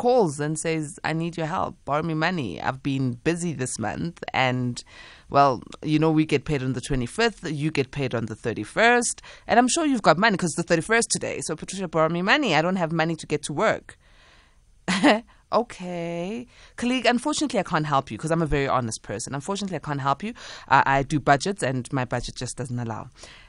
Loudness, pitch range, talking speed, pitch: -24 LUFS, 130-180 Hz, 210 wpm, 155 Hz